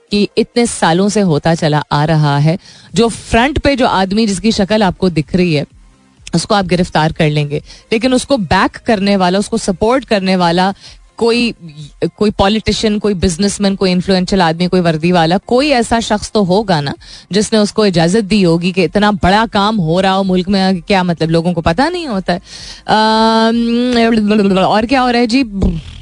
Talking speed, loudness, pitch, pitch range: 175 wpm, -13 LUFS, 195 Hz, 175-220 Hz